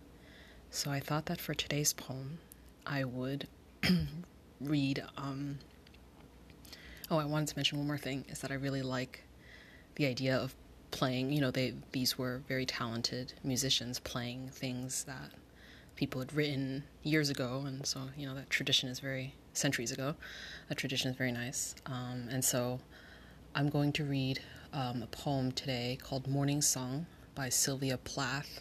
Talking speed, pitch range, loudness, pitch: 160 wpm, 125-140 Hz, -36 LUFS, 135 Hz